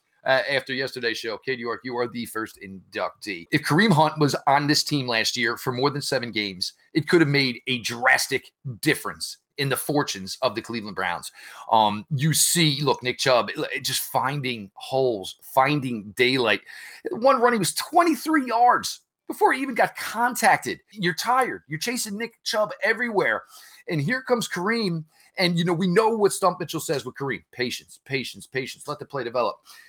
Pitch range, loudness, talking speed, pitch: 120-190 Hz, -23 LUFS, 180 wpm, 145 Hz